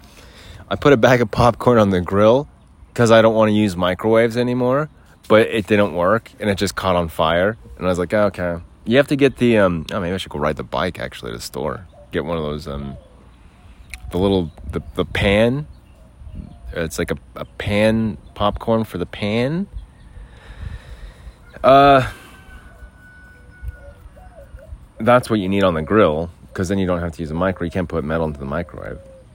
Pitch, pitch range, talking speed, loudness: 95 Hz, 85-110 Hz, 190 wpm, -18 LUFS